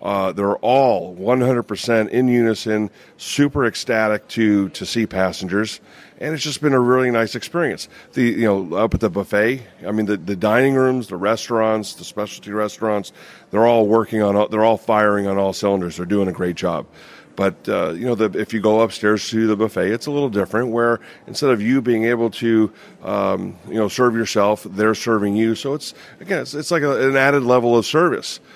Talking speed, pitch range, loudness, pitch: 200 wpm, 105-120 Hz, -19 LUFS, 110 Hz